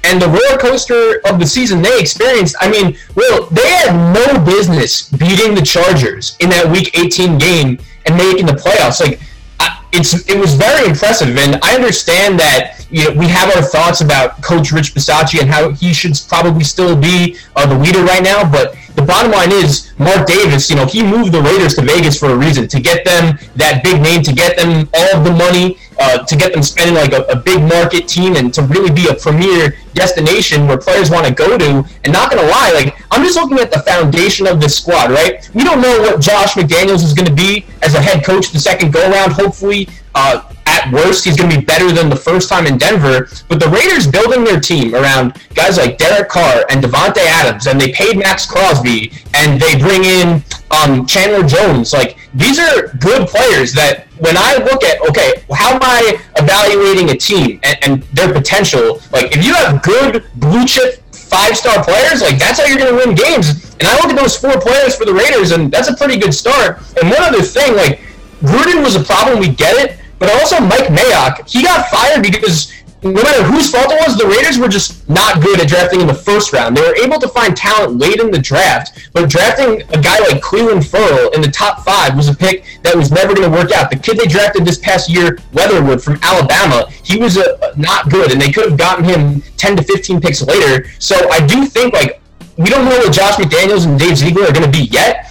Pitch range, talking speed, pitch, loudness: 150-200 Hz, 225 wpm, 175 Hz, -9 LUFS